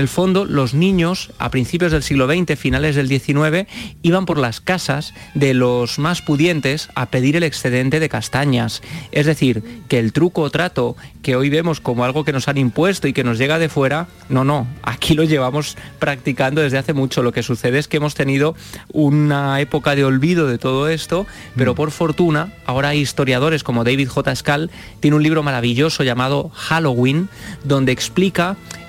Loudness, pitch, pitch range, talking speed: -17 LUFS, 145 Hz, 130-160 Hz, 185 wpm